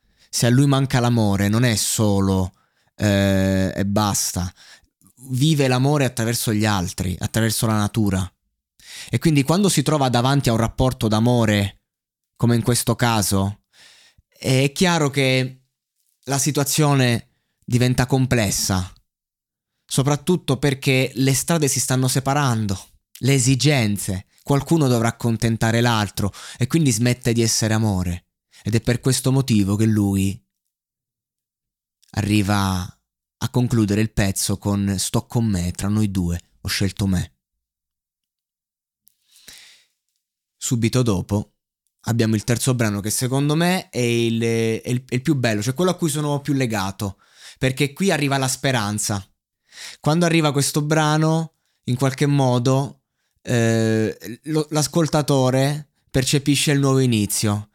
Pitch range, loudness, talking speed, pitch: 105-135 Hz, -20 LUFS, 130 wpm, 120 Hz